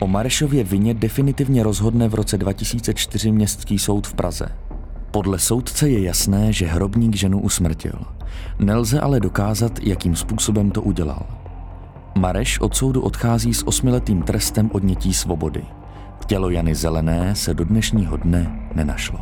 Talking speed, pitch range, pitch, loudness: 135 wpm, 90-110 Hz, 100 Hz, -19 LUFS